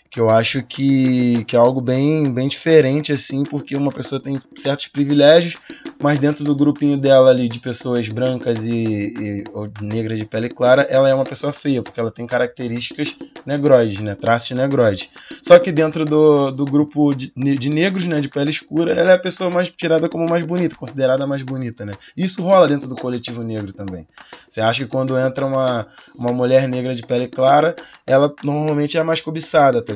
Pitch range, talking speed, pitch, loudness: 125-150 Hz, 195 wpm, 135 Hz, -17 LUFS